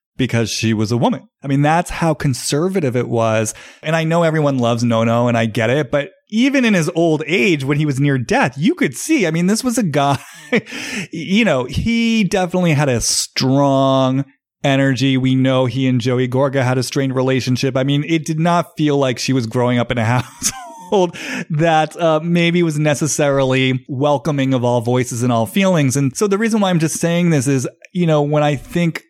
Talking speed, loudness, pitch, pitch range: 210 wpm, -16 LUFS, 145 Hz, 130-170 Hz